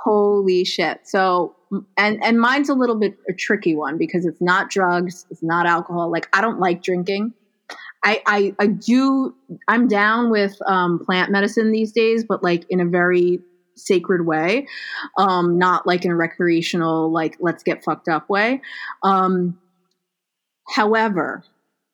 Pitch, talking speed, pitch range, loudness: 185 Hz, 155 wpm, 175-210 Hz, -19 LUFS